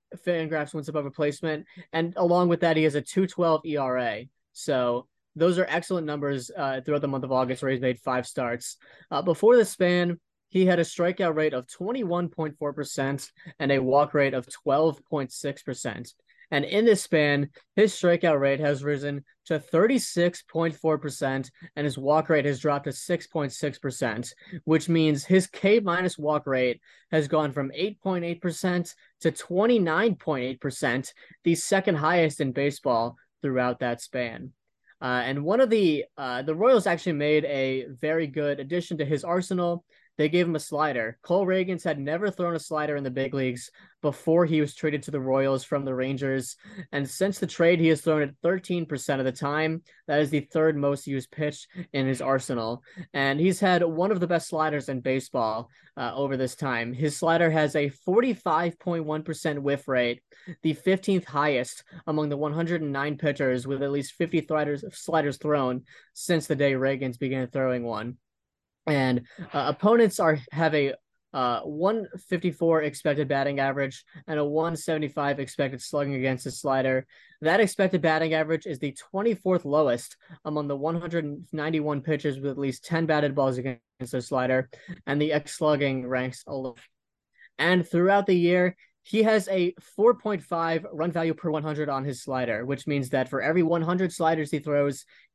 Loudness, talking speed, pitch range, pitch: -26 LUFS, 185 wpm, 135-170 Hz, 150 Hz